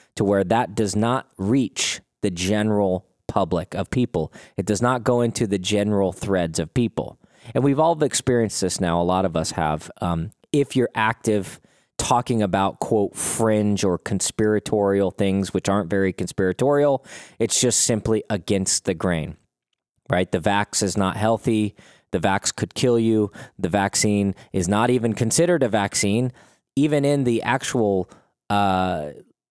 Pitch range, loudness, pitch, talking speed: 95-120 Hz, -22 LUFS, 105 Hz, 155 wpm